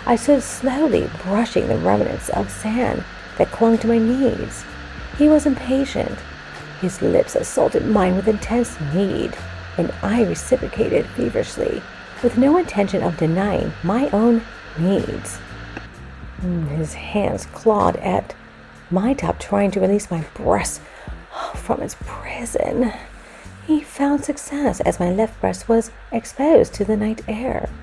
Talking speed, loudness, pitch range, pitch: 135 wpm, -20 LUFS, 190-265 Hz, 225 Hz